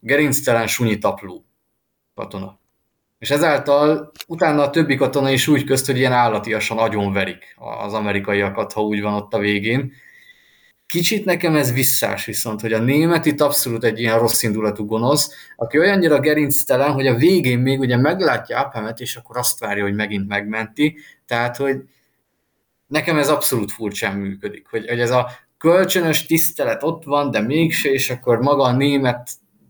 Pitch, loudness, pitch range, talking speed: 130 Hz, -18 LUFS, 110-150 Hz, 160 wpm